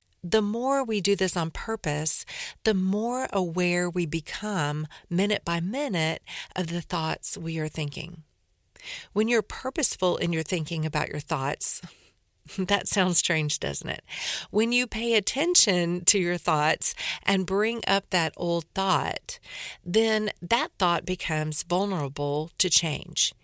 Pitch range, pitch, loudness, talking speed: 160-205 Hz, 180 Hz, -25 LUFS, 140 wpm